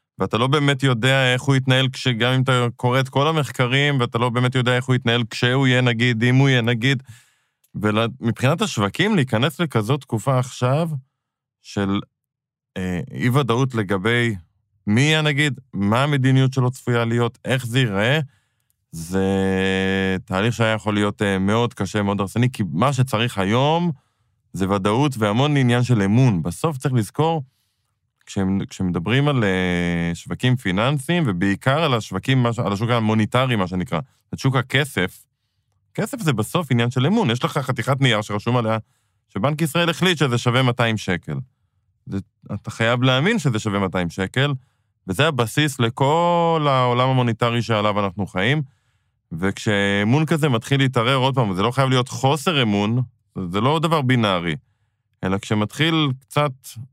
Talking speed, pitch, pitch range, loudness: 155 wpm, 120 Hz, 105-135 Hz, -20 LUFS